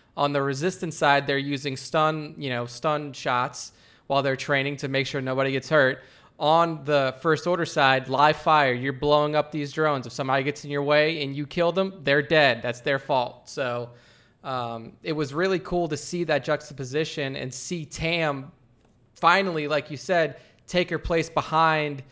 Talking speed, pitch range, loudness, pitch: 180 wpm, 135-155 Hz, -24 LUFS, 145 Hz